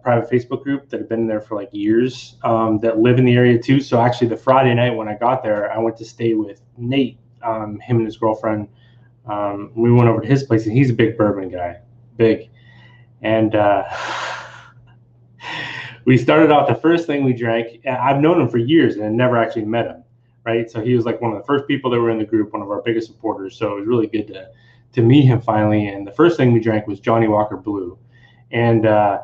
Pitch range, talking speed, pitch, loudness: 110-125 Hz, 235 wpm, 115 Hz, -18 LUFS